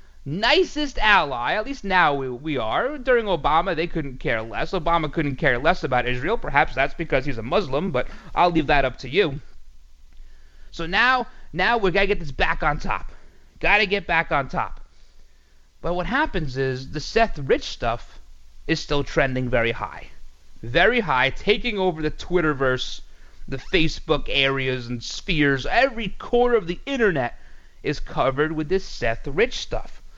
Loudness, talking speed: -22 LUFS, 170 wpm